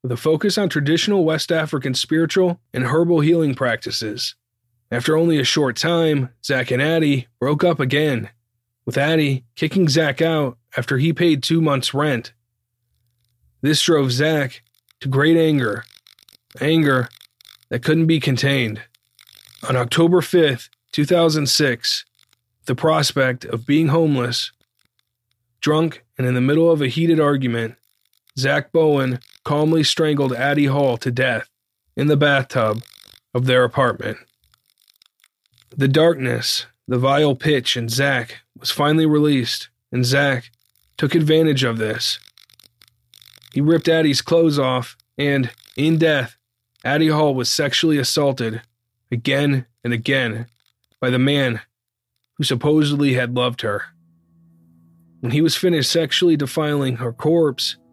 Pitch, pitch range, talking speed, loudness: 135 Hz, 120-155 Hz, 130 wpm, -18 LUFS